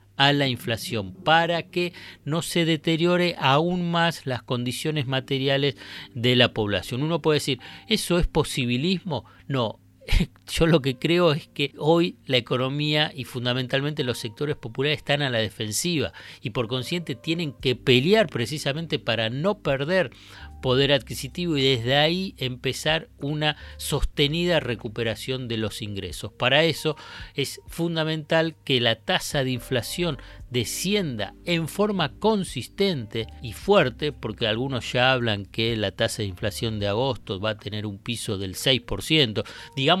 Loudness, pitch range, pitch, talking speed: -24 LUFS, 115-160 Hz, 135 Hz, 145 wpm